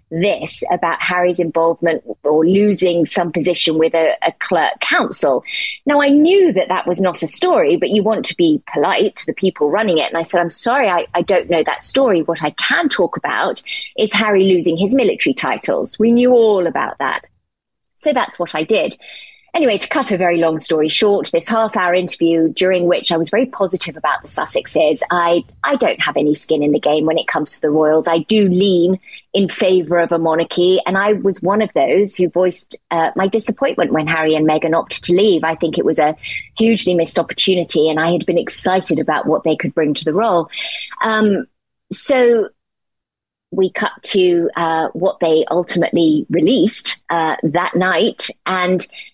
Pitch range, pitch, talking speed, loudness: 165-210 Hz, 180 Hz, 200 wpm, -15 LUFS